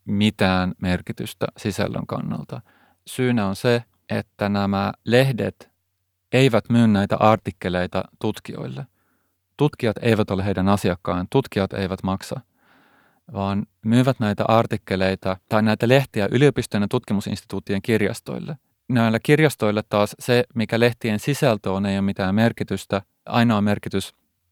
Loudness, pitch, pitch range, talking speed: -22 LUFS, 105 Hz, 95-115 Hz, 115 wpm